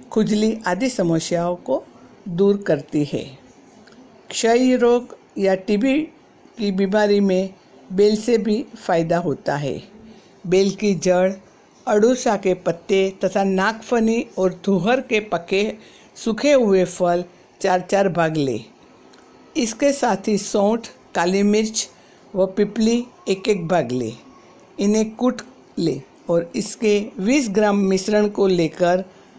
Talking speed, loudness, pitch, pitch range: 125 wpm, -20 LUFS, 200 Hz, 185-220 Hz